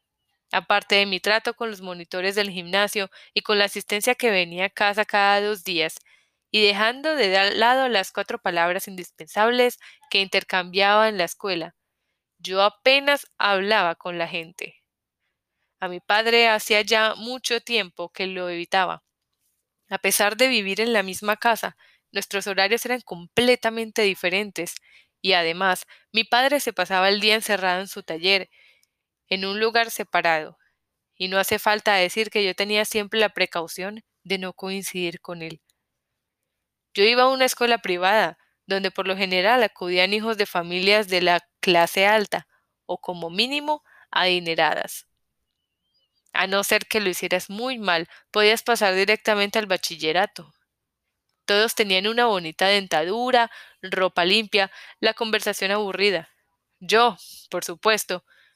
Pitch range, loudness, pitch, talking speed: 185-220 Hz, -21 LUFS, 200 Hz, 145 wpm